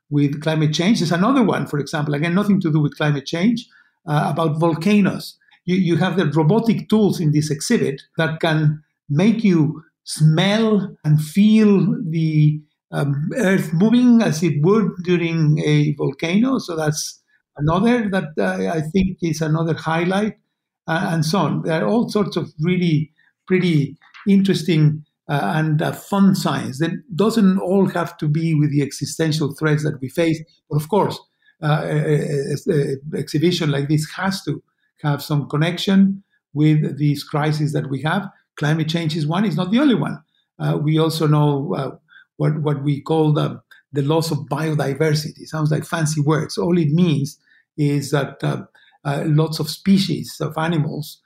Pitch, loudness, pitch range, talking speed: 160 Hz, -19 LUFS, 150-185 Hz, 170 wpm